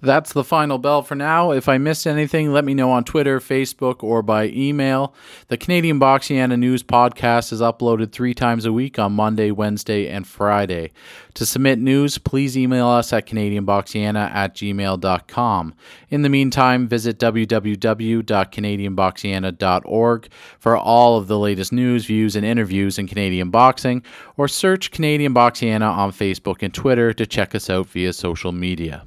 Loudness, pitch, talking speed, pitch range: -18 LUFS, 115 Hz, 160 wpm, 100-135 Hz